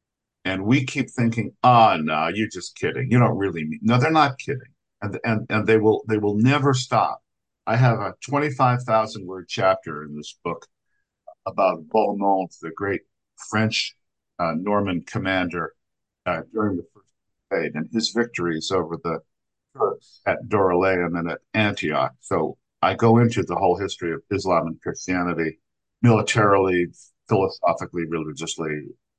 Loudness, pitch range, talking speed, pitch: -22 LUFS, 90-115 Hz, 155 wpm, 105 Hz